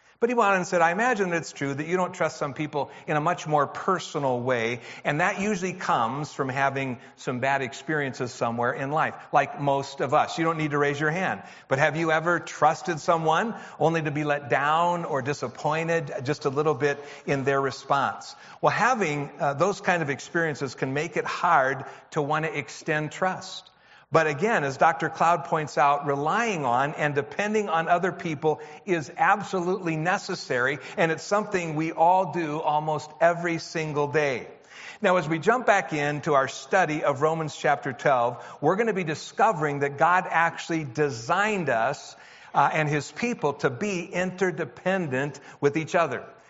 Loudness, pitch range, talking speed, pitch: -25 LUFS, 145-175 Hz, 180 wpm, 155 Hz